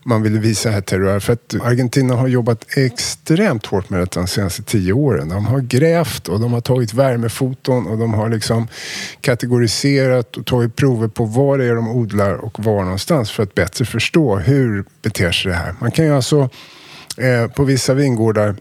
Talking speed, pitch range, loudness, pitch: 190 wpm, 110-130 Hz, -17 LUFS, 120 Hz